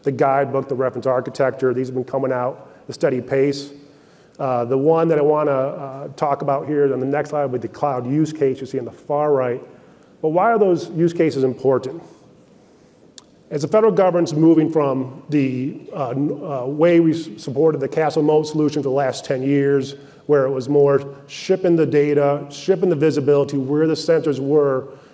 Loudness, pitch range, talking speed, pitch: -19 LUFS, 135-155 Hz, 200 wpm, 145 Hz